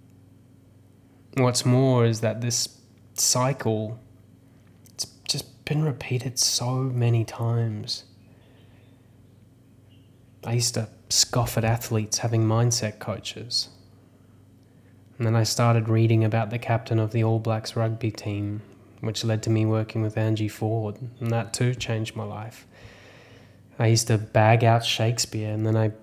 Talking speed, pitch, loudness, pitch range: 135 wpm, 115 Hz, -24 LUFS, 110-120 Hz